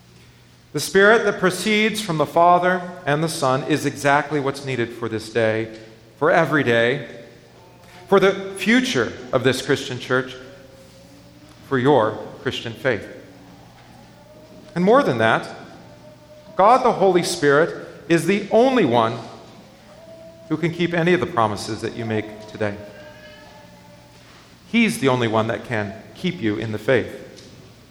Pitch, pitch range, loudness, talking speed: 130 Hz, 110-170 Hz, -20 LUFS, 140 wpm